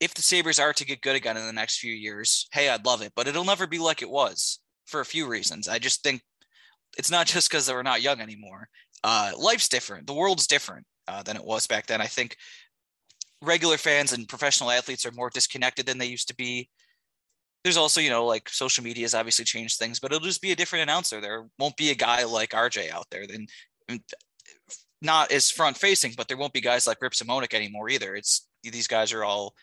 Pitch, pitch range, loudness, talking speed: 125 Hz, 115-155 Hz, -24 LUFS, 230 wpm